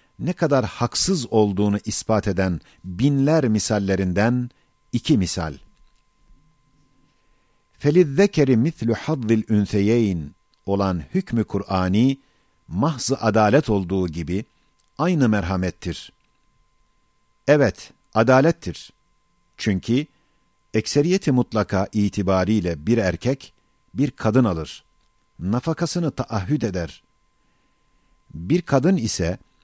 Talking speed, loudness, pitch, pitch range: 80 wpm, -21 LUFS, 115 Hz, 100-145 Hz